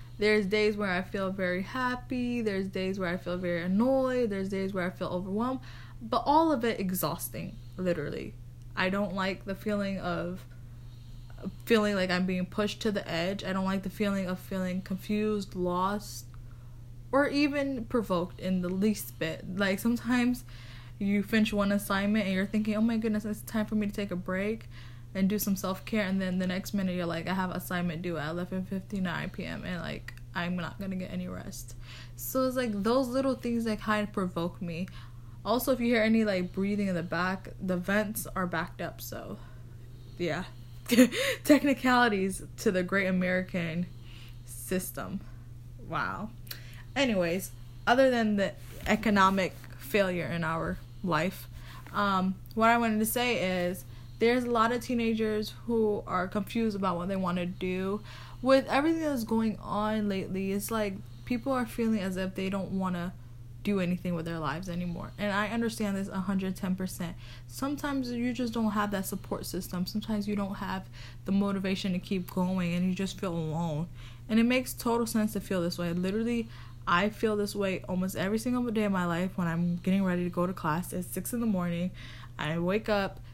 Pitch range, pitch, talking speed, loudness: 170-215 Hz, 190 Hz, 185 wpm, -30 LUFS